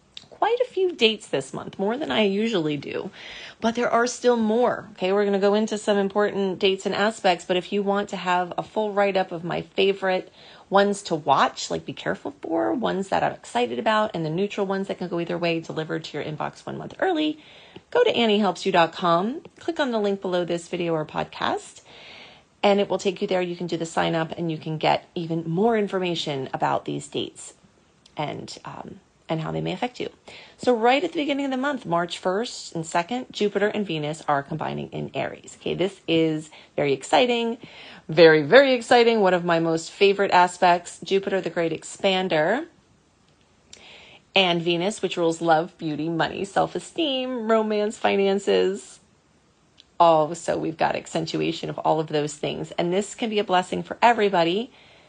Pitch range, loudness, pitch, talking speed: 170-215 Hz, -23 LUFS, 190 Hz, 190 wpm